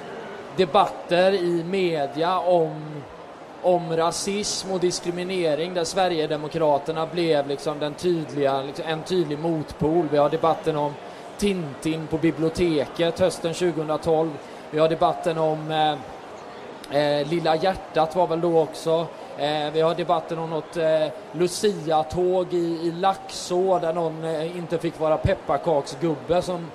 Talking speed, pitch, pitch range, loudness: 130 wpm, 165 Hz, 155-175 Hz, -24 LUFS